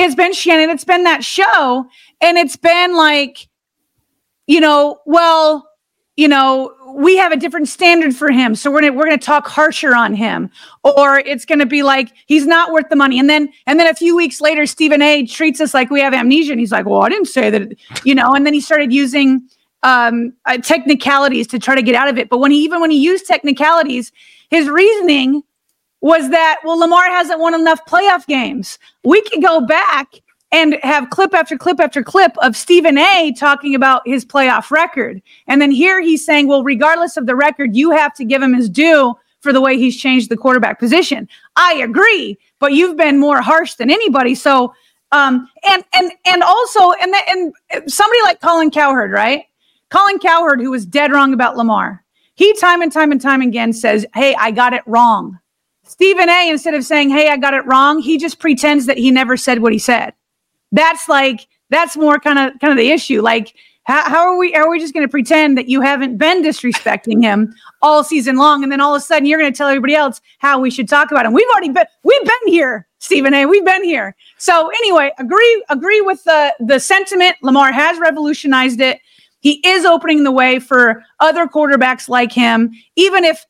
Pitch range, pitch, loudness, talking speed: 265-330 Hz, 295 Hz, -11 LUFS, 210 wpm